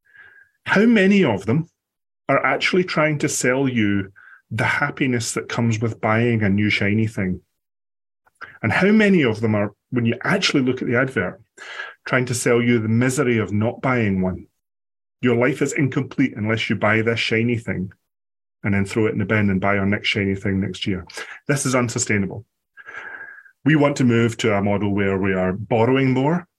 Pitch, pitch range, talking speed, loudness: 115 Hz, 100-135 Hz, 185 wpm, -20 LUFS